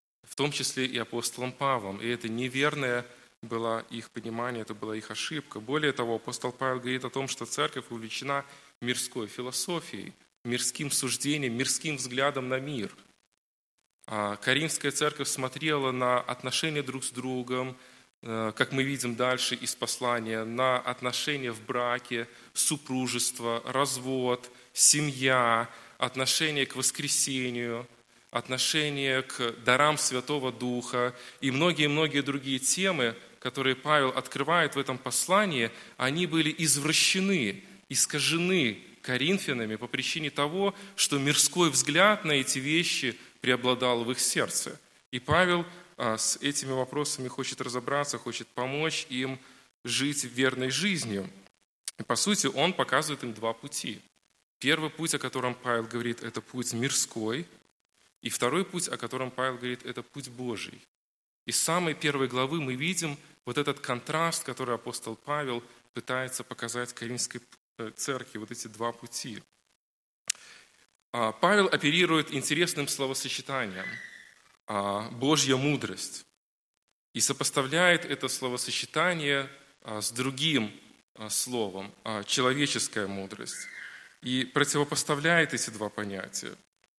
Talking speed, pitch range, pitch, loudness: 120 wpm, 120-145 Hz, 130 Hz, -28 LUFS